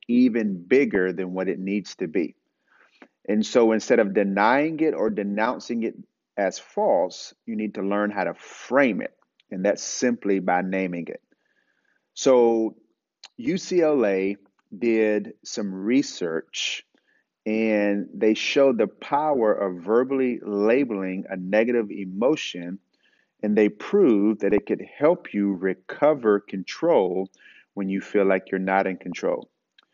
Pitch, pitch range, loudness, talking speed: 105 Hz, 95-110 Hz, -23 LUFS, 135 wpm